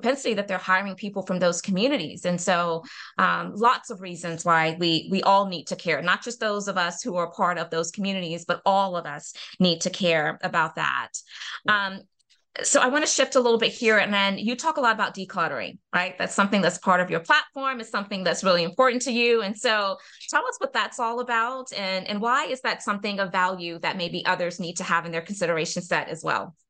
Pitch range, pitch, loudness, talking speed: 175-230 Hz, 190 Hz, -24 LUFS, 225 wpm